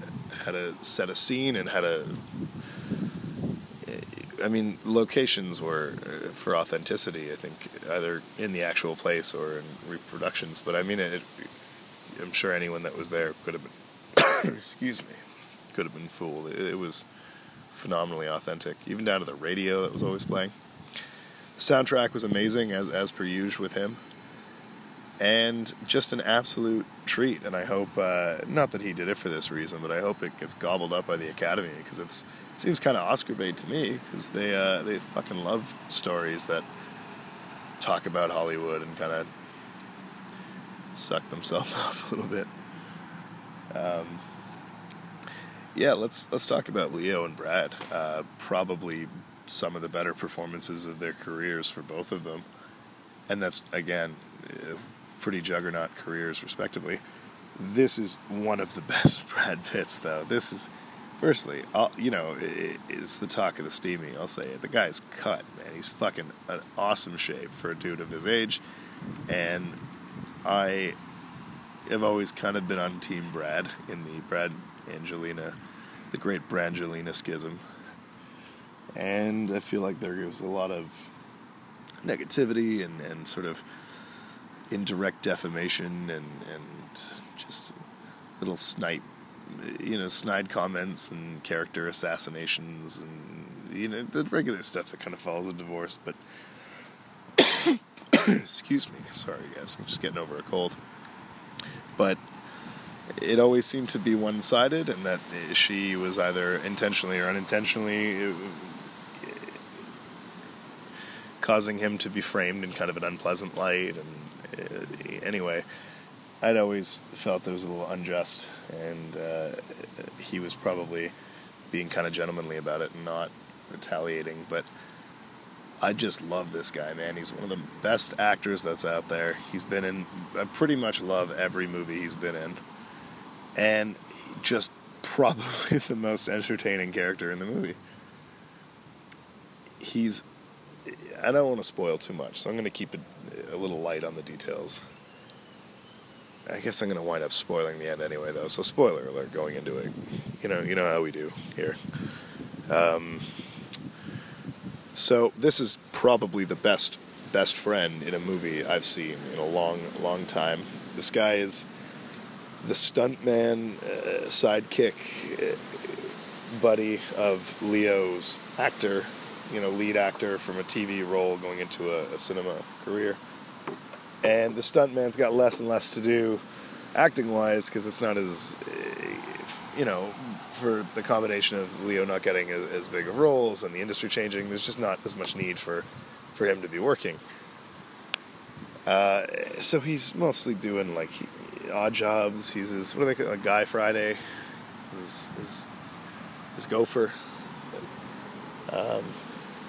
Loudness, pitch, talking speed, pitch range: -28 LUFS, 95 Hz, 155 wpm, 85-110 Hz